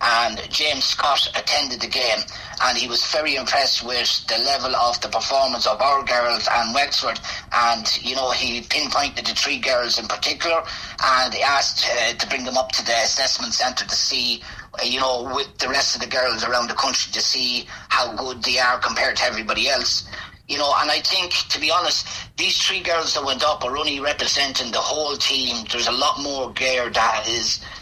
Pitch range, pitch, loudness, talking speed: 120-135 Hz, 125 Hz, -19 LUFS, 205 wpm